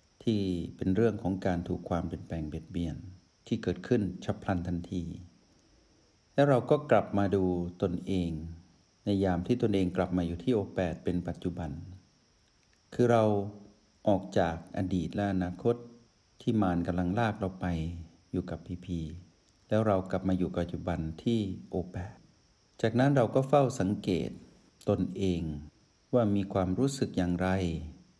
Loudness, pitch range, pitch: -31 LUFS, 85-105 Hz, 95 Hz